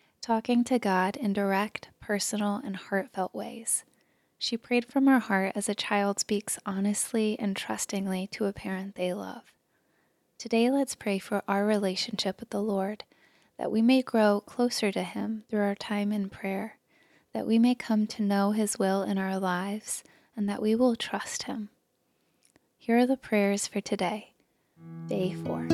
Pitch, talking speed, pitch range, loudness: 205 Hz, 170 wpm, 195-225 Hz, -29 LUFS